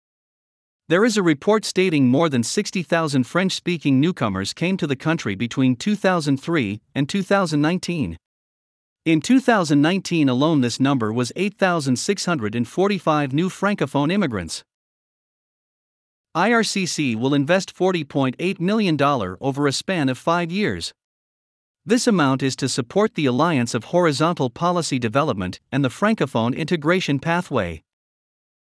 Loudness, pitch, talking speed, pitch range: -20 LUFS, 155 Hz, 115 wpm, 135-185 Hz